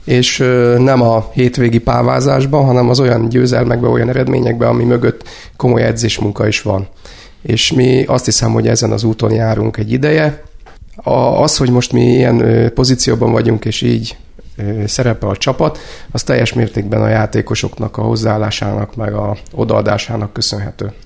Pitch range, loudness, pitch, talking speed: 110-125 Hz, -13 LUFS, 115 Hz, 150 wpm